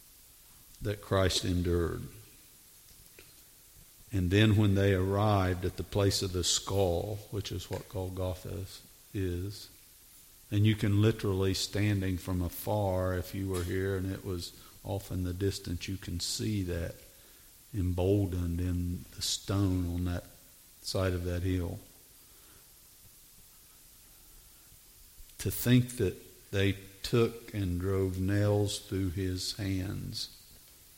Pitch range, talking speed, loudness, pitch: 90-105 Hz, 120 wpm, -32 LUFS, 95 Hz